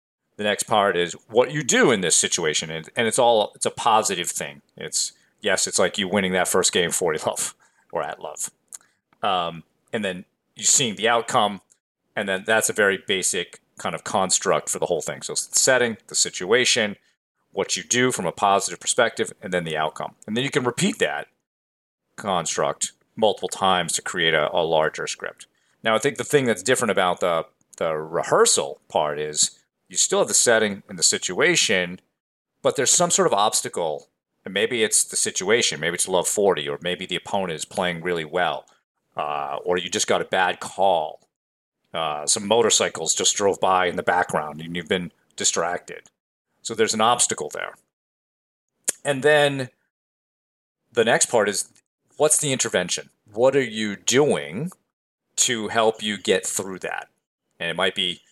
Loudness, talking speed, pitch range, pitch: -21 LUFS, 180 wpm, 90-140 Hz, 110 Hz